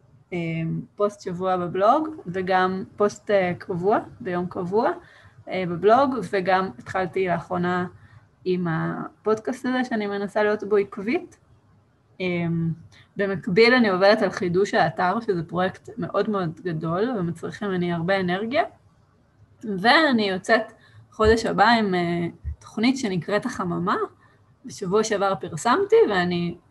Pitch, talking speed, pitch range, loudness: 190 Hz, 105 wpm, 175-215 Hz, -23 LUFS